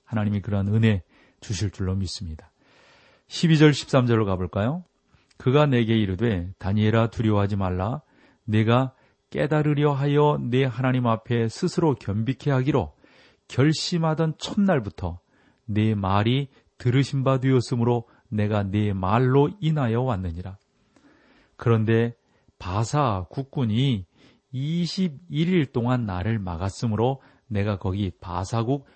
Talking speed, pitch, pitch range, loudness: 250 characters per minute, 120 Hz, 105-135 Hz, -24 LUFS